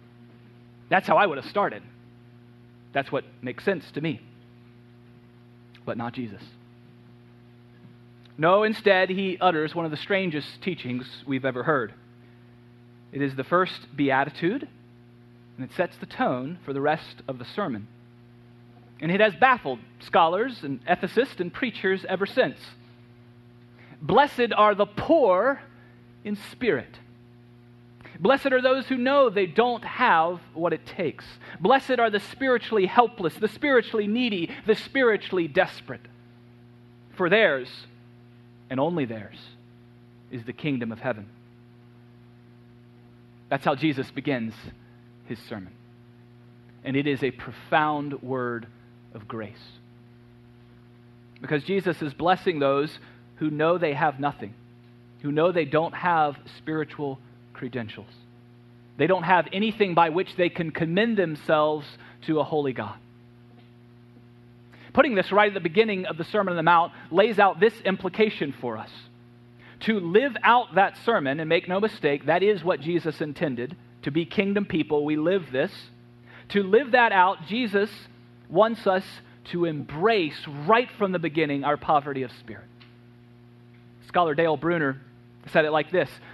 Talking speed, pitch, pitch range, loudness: 140 wpm, 135 Hz, 120-180 Hz, -24 LUFS